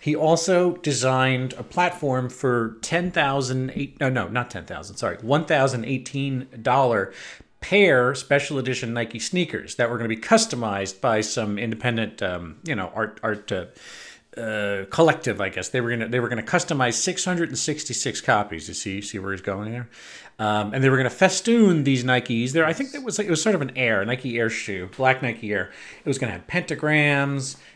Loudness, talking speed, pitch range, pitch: -23 LUFS, 210 wpm, 115-150 Hz, 125 Hz